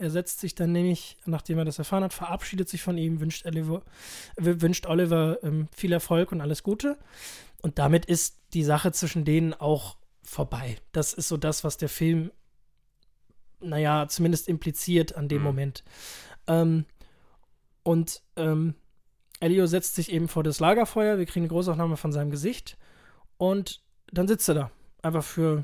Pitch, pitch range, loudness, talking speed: 165 Hz, 155-175 Hz, -27 LUFS, 165 wpm